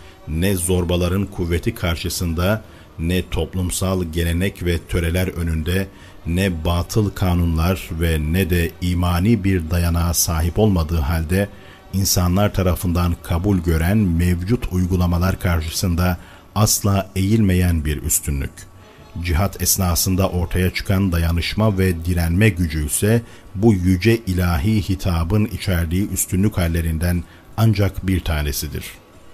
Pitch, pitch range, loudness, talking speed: 90 Hz, 85-95 Hz, -19 LUFS, 105 wpm